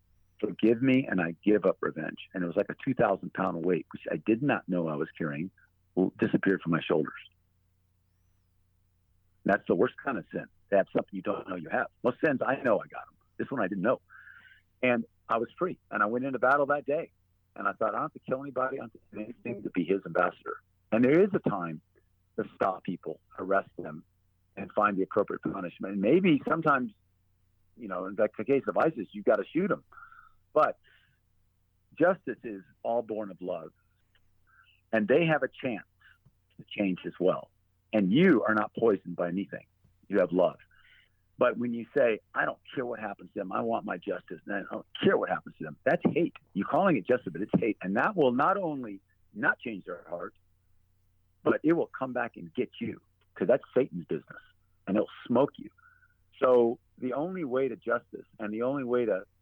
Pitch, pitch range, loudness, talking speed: 95 Hz, 90-120 Hz, -30 LUFS, 210 wpm